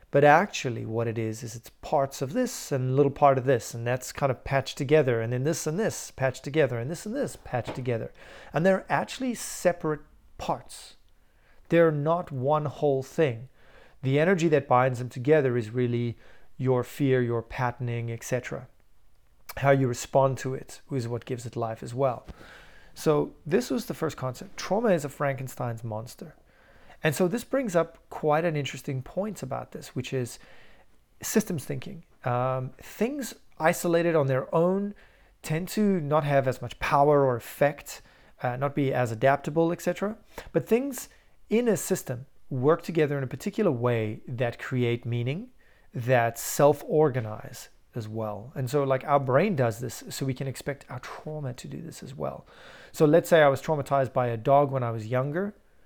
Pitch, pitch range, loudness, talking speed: 140 Hz, 125-165 Hz, -27 LUFS, 180 wpm